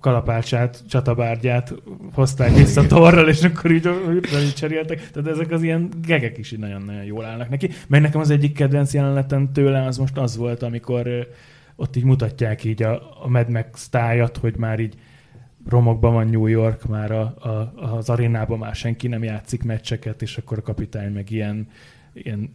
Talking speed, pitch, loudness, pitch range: 175 wpm, 120 Hz, -20 LUFS, 115-140 Hz